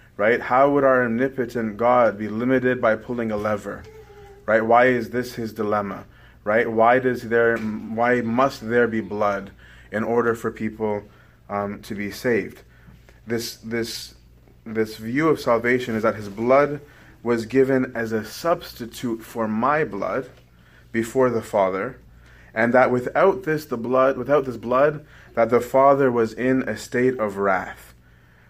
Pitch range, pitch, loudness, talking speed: 110-125 Hz, 115 Hz, -22 LUFS, 155 wpm